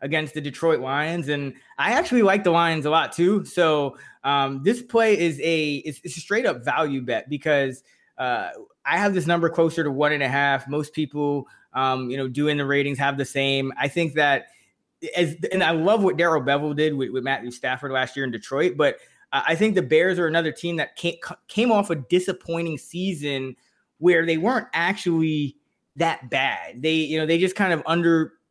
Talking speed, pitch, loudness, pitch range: 205 wpm, 155 Hz, -23 LUFS, 140-170 Hz